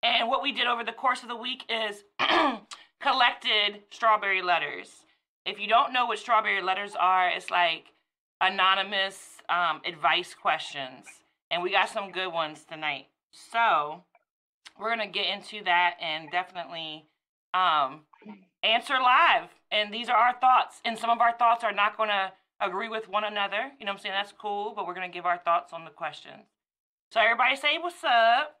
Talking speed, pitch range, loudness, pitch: 185 wpm, 180-235 Hz, -26 LUFS, 205 Hz